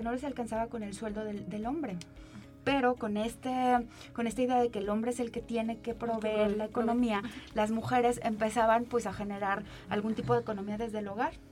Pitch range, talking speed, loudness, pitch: 215-240 Hz, 210 wpm, -32 LUFS, 230 Hz